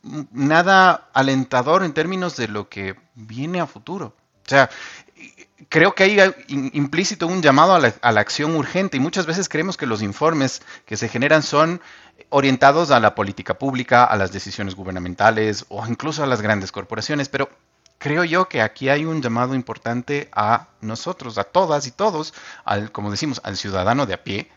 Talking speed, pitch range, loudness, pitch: 180 wpm, 110-155 Hz, -19 LUFS, 135 Hz